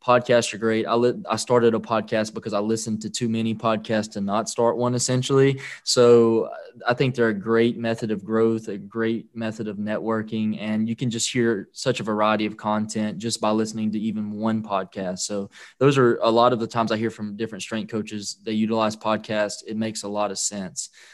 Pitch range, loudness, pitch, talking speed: 105-115 Hz, -23 LUFS, 110 Hz, 215 wpm